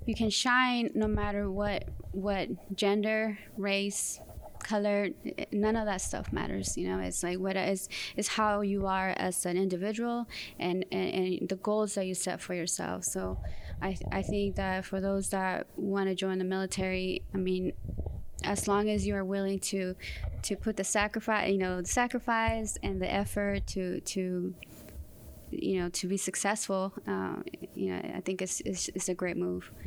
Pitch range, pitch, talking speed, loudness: 185-205 Hz, 195 Hz, 175 wpm, -32 LUFS